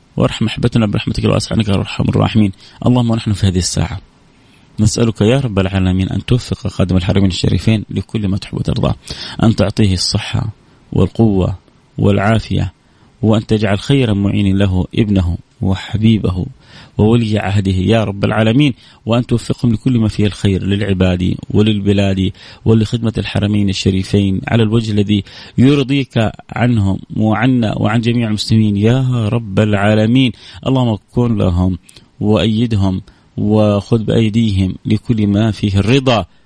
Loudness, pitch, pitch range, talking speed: -15 LUFS, 105 Hz, 100-115 Hz, 125 wpm